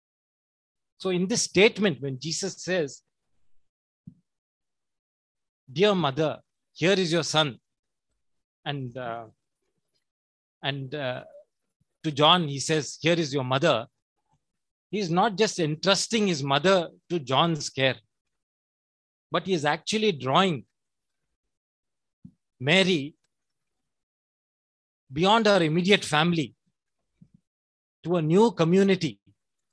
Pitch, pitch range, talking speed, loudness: 160 Hz, 135-185 Hz, 100 wpm, -24 LUFS